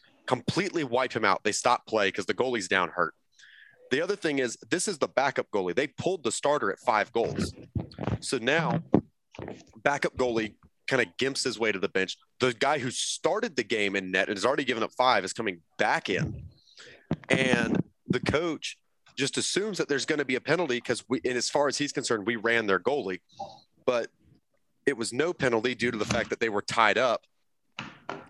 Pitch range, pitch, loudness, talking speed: 110-145 Hz, 125 Hz, -28 LUFS, 205 wpm